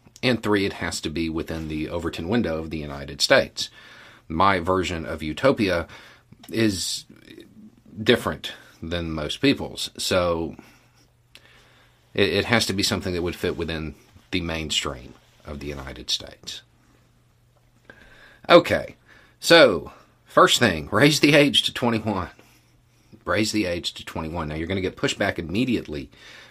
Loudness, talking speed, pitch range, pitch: -22 LUFS, 140 wpm, 80-110 Hz, 85 Hz